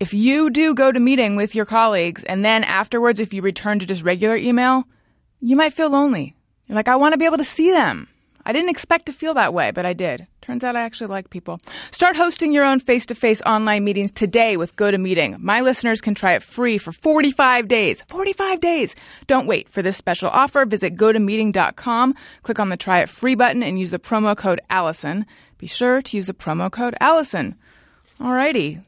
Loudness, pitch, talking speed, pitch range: -18 LUFS, 230 Hz, 215 wpm, 195-270 Hz